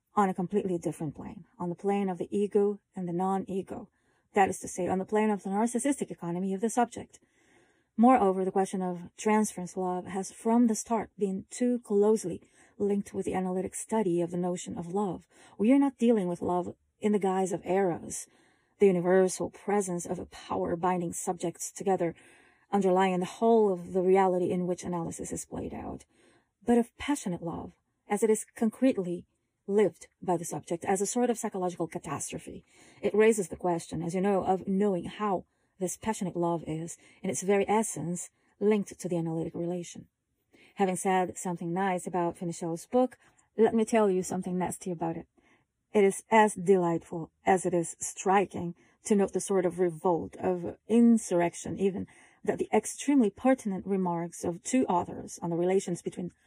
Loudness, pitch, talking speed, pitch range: -29 LUFS, 190 Hz, 180 wpm, 175-210 Hz